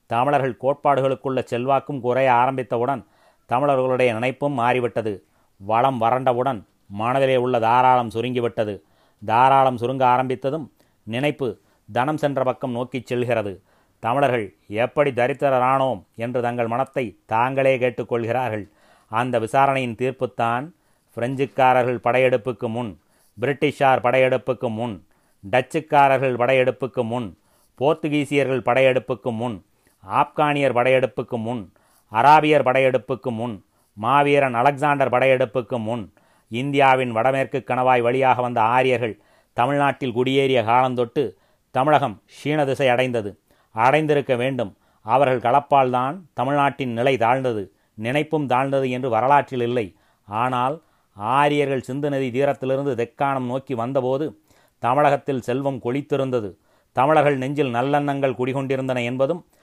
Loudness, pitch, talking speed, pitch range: -21 LUFS, 130 Hz, 100 wpm, 120-135 Hz